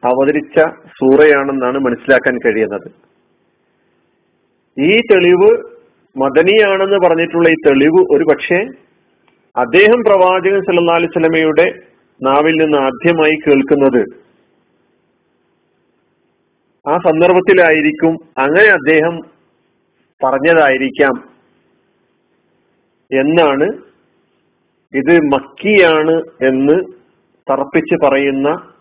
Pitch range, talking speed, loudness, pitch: 140-180 Hz, 65 wpm, -11 LUFS, 160 Hz